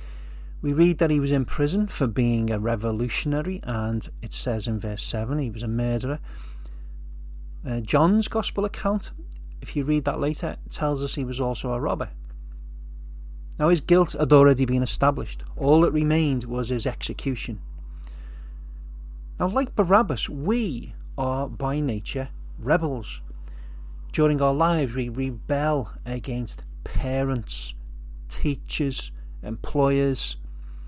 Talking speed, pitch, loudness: 130 wpm, 125 Hz, -25 LUFS